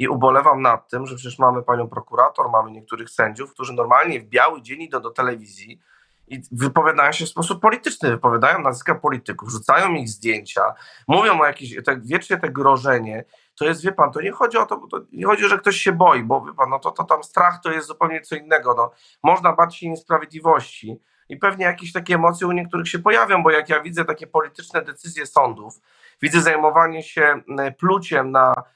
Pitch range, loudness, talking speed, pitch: 130-175 Hz, -18 LUFS, 200 wpm, 160 Hz